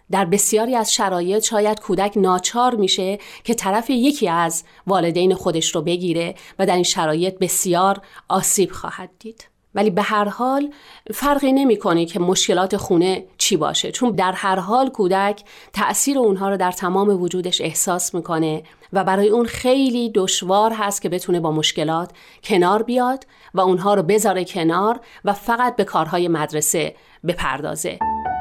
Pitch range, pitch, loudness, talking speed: 180-215 Hz, 195 Hz, -19 LUFS, 150 wpm